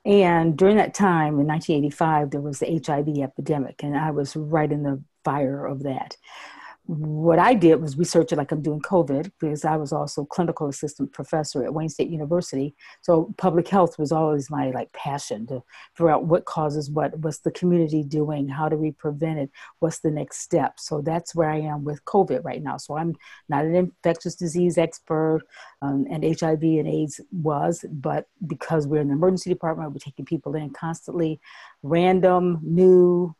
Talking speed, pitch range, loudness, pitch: 185 wpm, 150-170 Hz, -23 LUFS, 155 Hz